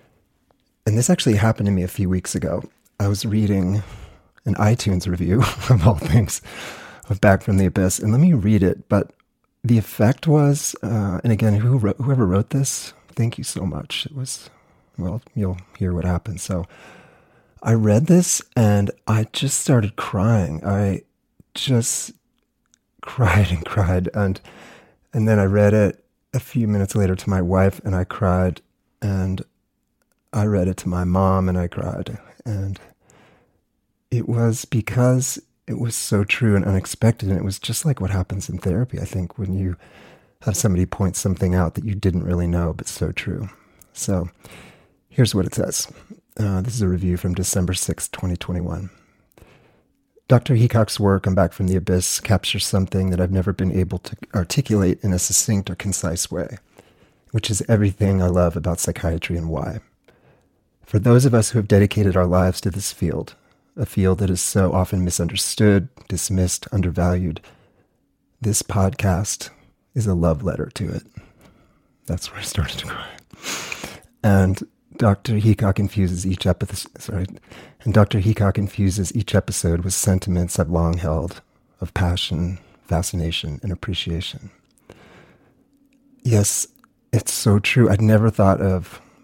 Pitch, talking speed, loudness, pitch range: 100 Hz, 160 wpm, -20 LUFS, 90-110 Hz